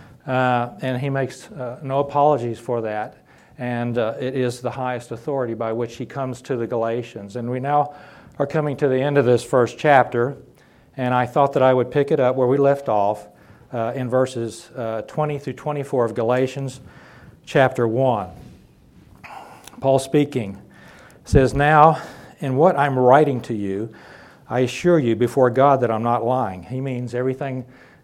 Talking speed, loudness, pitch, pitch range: 175 wpm, -20 LUFS, 125 Hz, 120-140 Hz